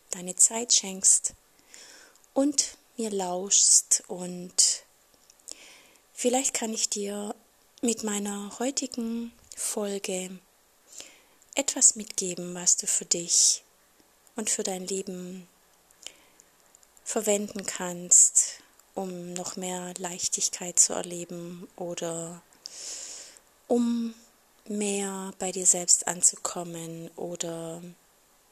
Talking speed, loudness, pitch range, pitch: 85 wpm, -25 LUFS, 180-230 Hz, 195 Hz